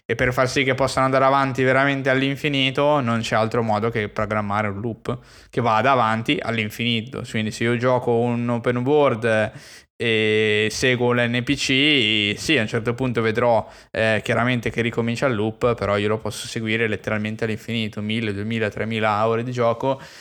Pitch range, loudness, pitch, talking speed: 110-130 Hz, -21 LUFS, 115 Hz, 170 wpm